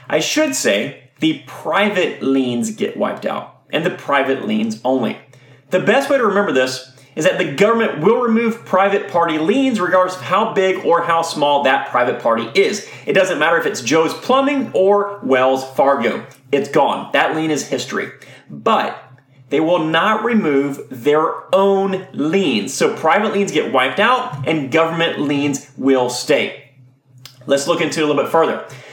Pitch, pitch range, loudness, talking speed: 160 Hz, 135-200 Hz, -17 LUFS, 170 wpm